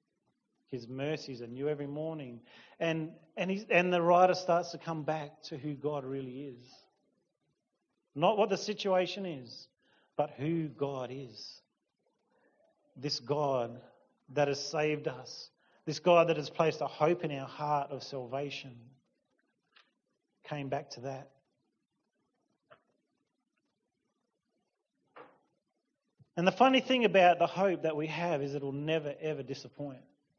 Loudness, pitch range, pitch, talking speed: -32 LUFS, 135-170 Hz, 150 Hz, 135 wpm